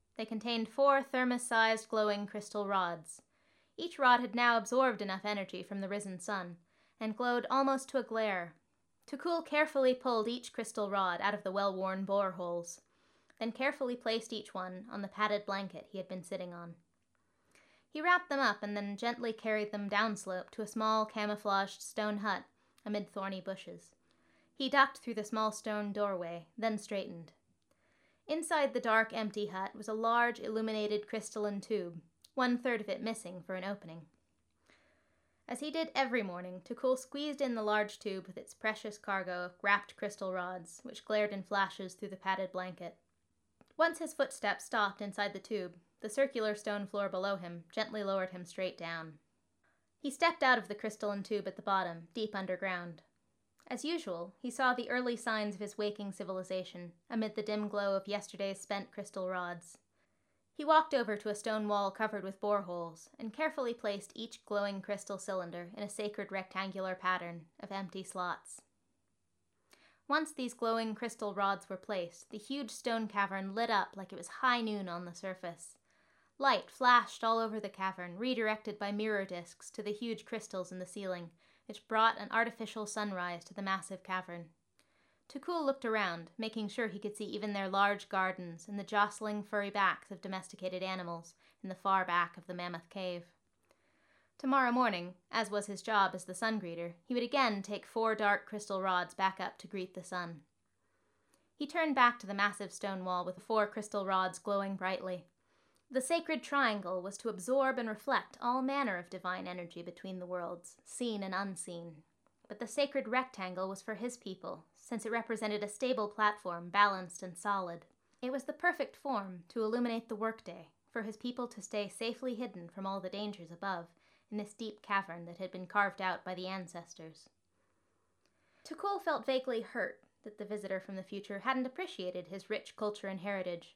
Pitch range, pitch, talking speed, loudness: 185-230 Hz, 205 Hz, 180 wpm, -36 LUFS